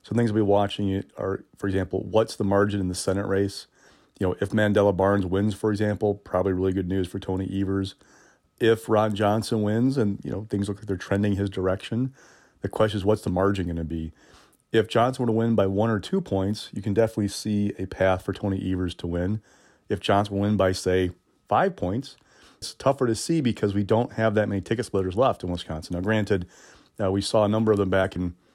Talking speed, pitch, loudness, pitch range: 230 wpm, 100 Hz, -25 LUFS, 95-110 Hz